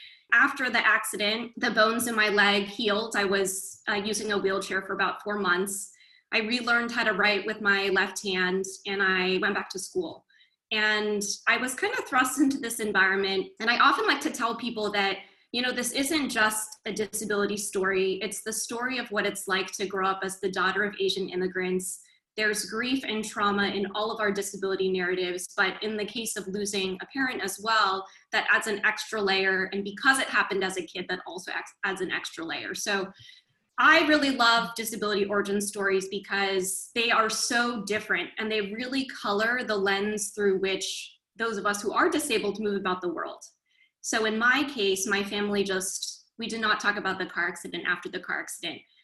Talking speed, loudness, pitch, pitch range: 200 wpm, -26 LUFS, 205 Hz, 195-225 Hz